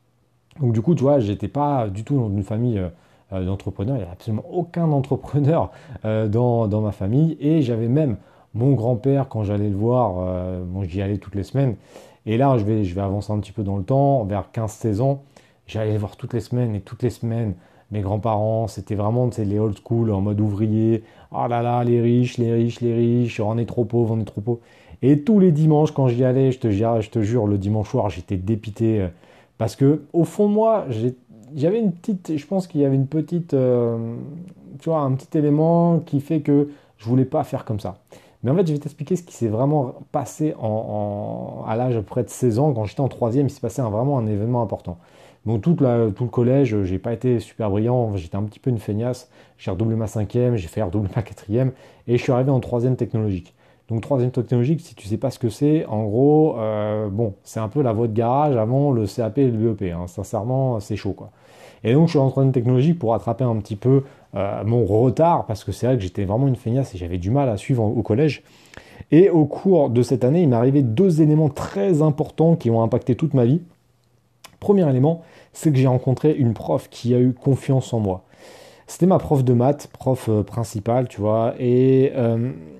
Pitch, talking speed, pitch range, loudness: 120 Hz, 235 wpm, 110-140 Hz, -21 LUFS